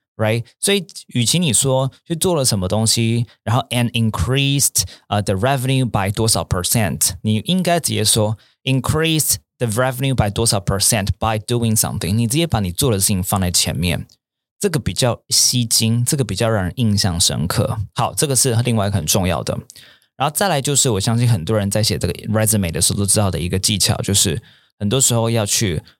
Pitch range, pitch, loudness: 100-130 Hz, 115 Hz, -17 LUFS